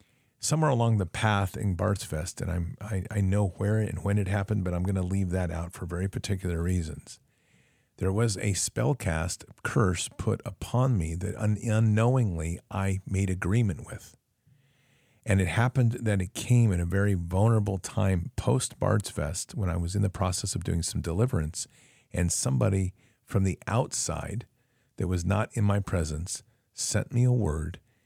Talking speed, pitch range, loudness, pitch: 175 wpm, 90-115 Hz, -28 LUFS, 105 Hz